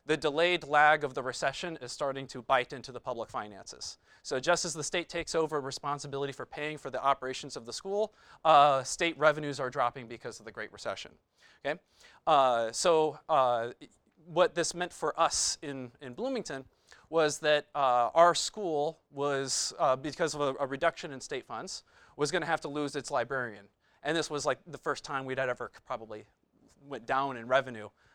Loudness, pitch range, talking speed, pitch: -31 LUFS, 130-160 Hz, 190 wpm, 145 Hz